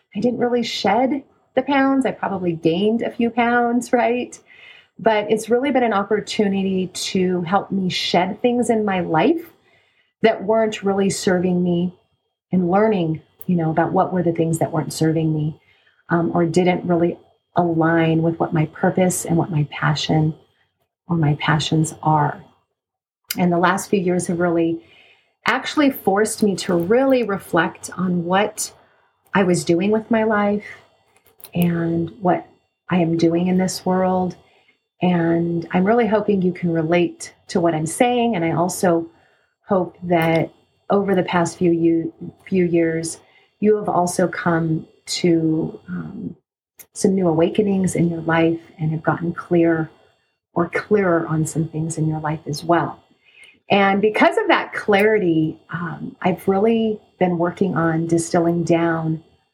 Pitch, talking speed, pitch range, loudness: 180 Hz, 150 wpm, 165-205 Hz, -19 LUFS